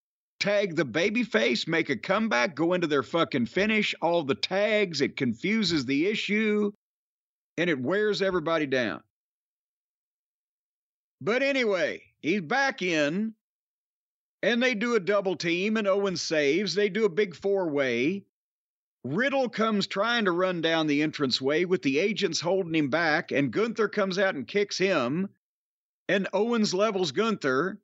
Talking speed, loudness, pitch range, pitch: 145 wpm, -26 LUFS, 170-215 Hz, 195 Hz